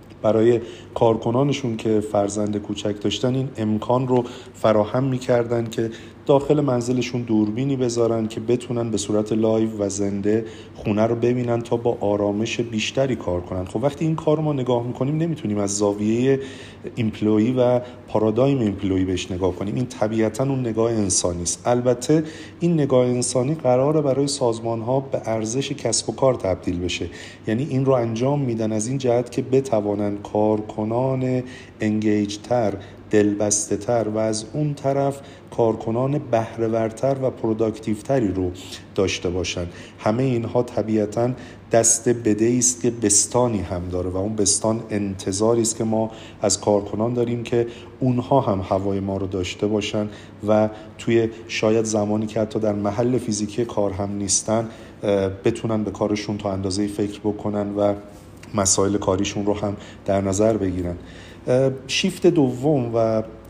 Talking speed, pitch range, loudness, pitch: 145 wpm, 105-125 Hz, -22 LUFS, 110 Hz